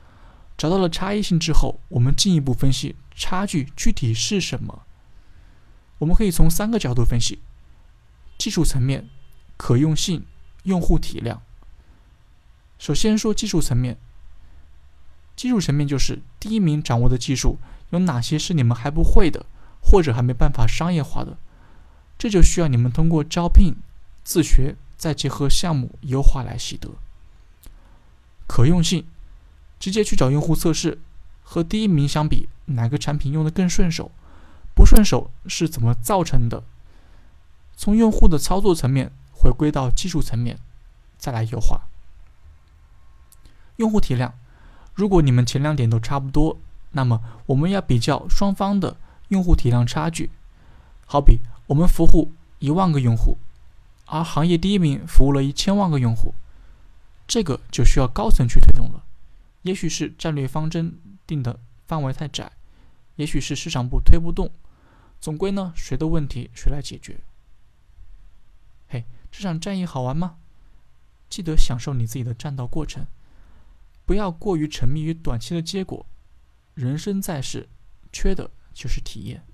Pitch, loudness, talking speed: 135 Hz, -22 LUFS, 230 characters per minute